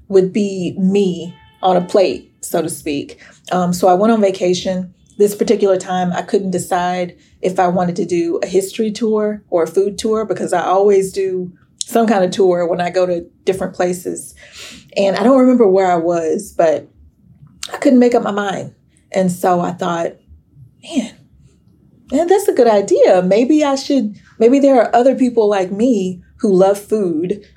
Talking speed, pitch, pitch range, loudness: 185 wpm, 190 Hz, 180-215 Hz, -15 LUFS